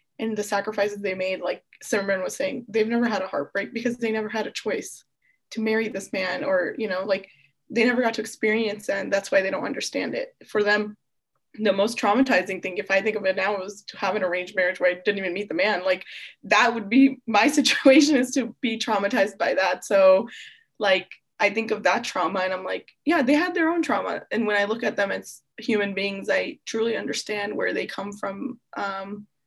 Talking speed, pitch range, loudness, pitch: 225 wpm, 195-240 Hz, -24 LUFS, 210 Hz